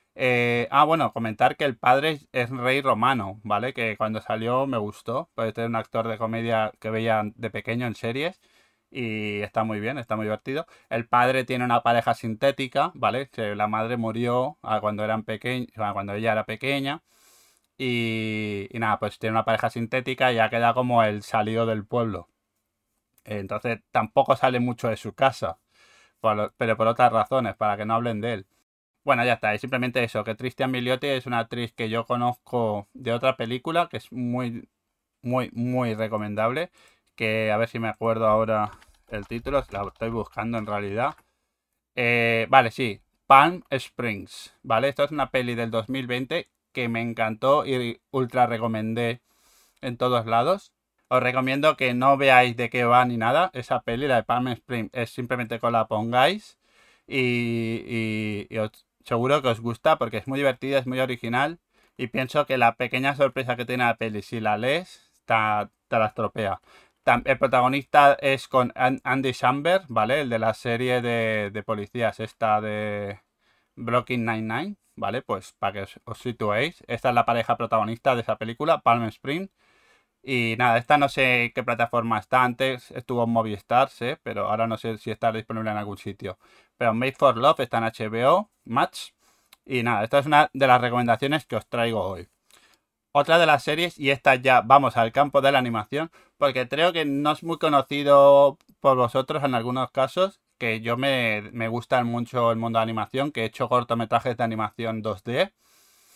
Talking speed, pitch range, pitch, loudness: 185 wpm, 110-130 Hz, 120 Hz, -24 LUFS